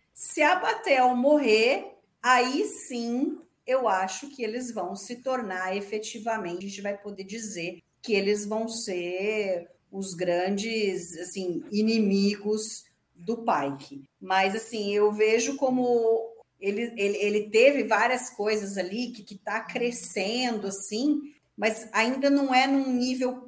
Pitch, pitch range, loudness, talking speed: 220 Hz, 195-250 Hz, -20 LUFS, 135 wpm